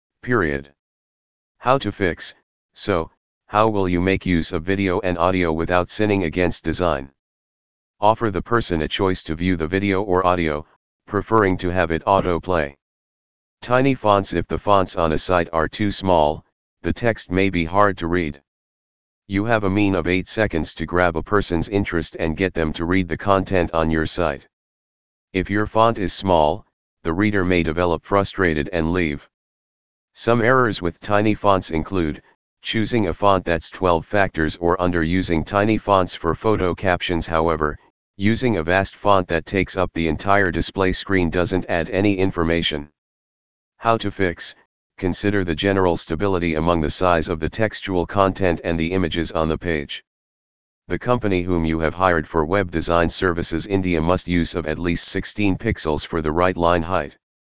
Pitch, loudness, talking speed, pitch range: 90 Hz, -20 LUFS, 170 wpm, 80-100 Hz